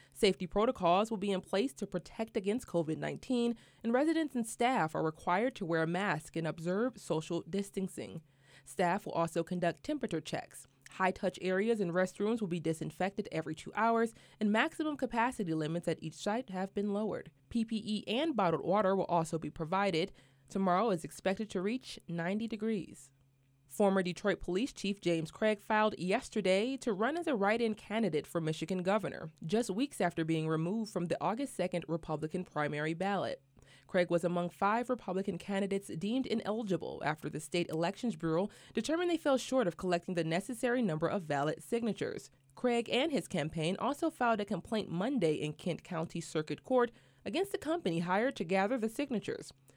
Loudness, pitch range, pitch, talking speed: -34 LUFS, 165-225 Hz, 190 Hz, 170 wpm